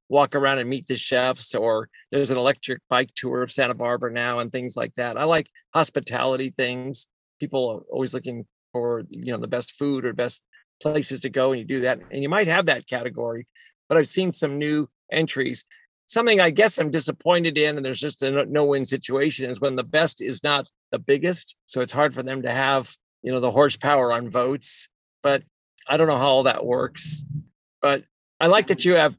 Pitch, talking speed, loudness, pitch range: 135 Hz, 210 wpm, -23 LUFS, 125-150 Hz